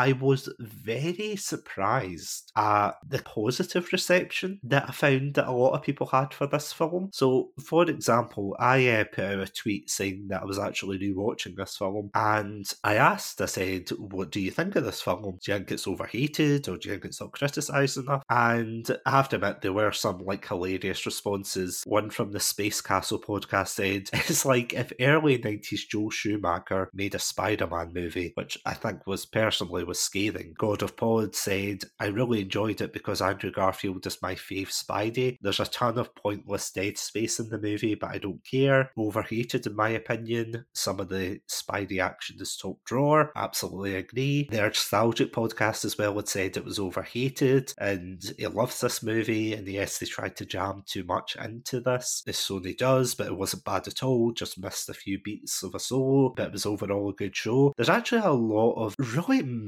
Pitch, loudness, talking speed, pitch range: 110 Hz, -28 LUFS, 200 wpm, 100-130 Hz